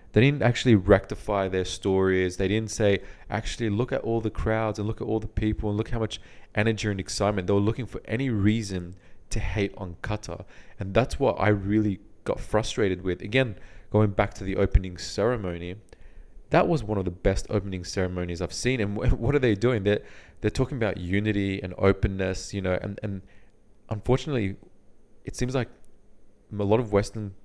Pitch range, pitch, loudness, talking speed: 95-110 Hz, 105 Hz, -26 LUFS, 190 wpm